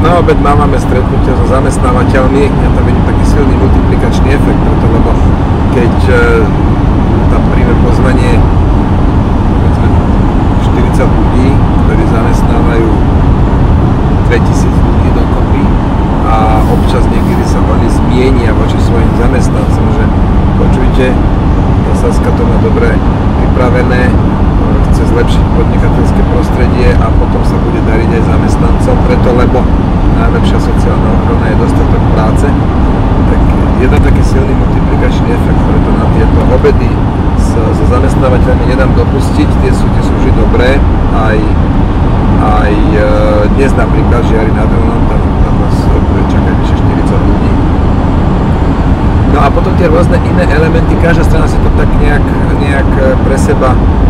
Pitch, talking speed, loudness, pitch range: 95 Hz, 130 wpm, -9 LUFS, 90-100 Hz